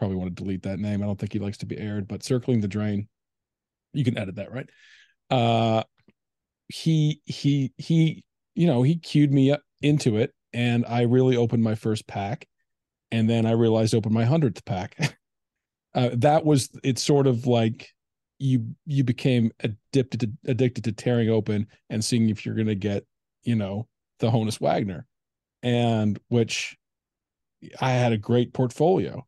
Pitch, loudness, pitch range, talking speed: 120 Hz, -24 LUFS, 110-135 Hz, 170 wpm